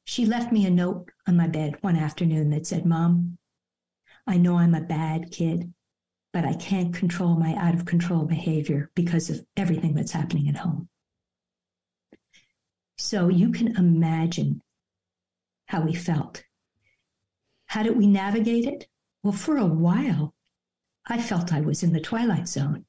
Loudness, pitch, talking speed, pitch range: -24 LUFS, 170 Hz, 155 wpm, 155-185 Hz